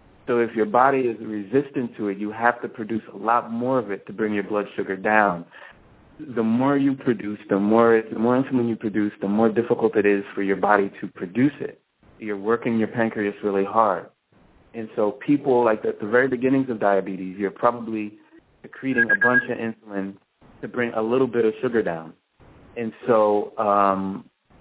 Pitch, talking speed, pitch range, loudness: 110 Hz, 195 wpm, 100-120 Hz, -22 LUFS